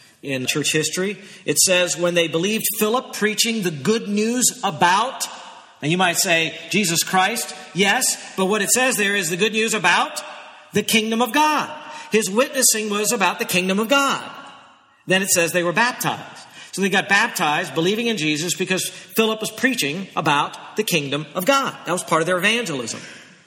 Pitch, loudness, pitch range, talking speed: 200 Hz, -19 LUFS, 180-235 Hz, 180 wpm